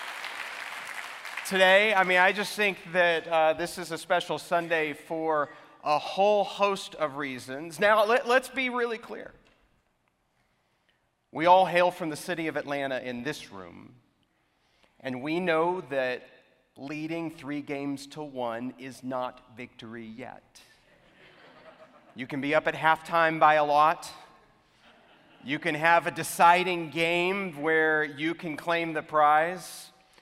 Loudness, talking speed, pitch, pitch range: -26 LUFS, 140 wpm, 160 Hz, 145-180 Hz